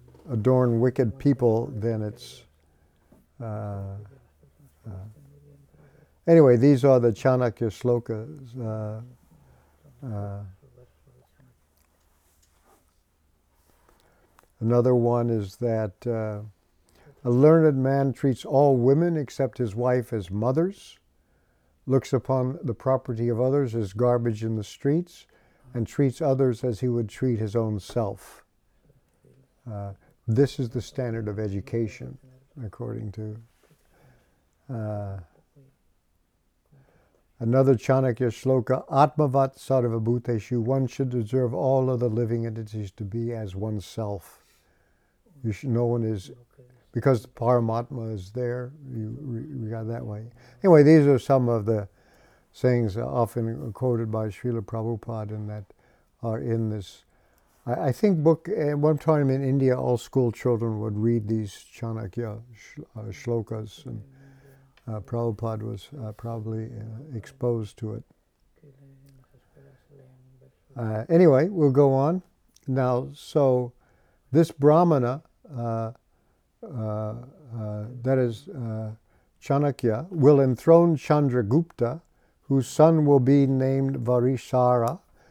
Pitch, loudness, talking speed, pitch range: 120 Hz, -24 LUFS, 115 wpm, 110-135 Hz